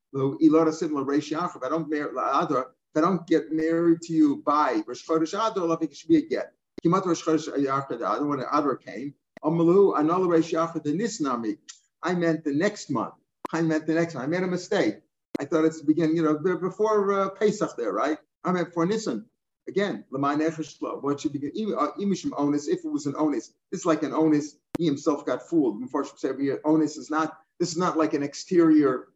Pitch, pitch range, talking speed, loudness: 160 Hz, 150-180 Hz, 180 wpm, -25 LUFS